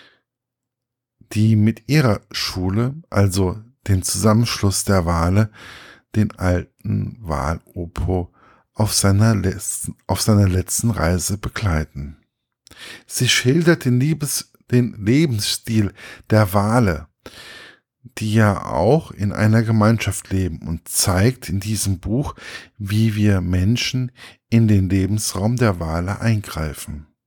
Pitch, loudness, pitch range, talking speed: 105 Hz, -19 LUFS, 95-115 Hz, 110 wpm